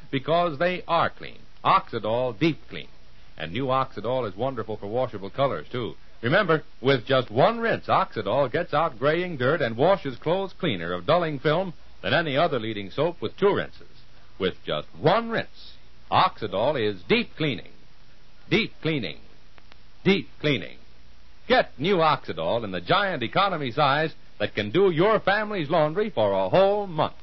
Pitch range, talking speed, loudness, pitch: 110-175 Hz, 155 wpm, -24 LUFS, 145 Hz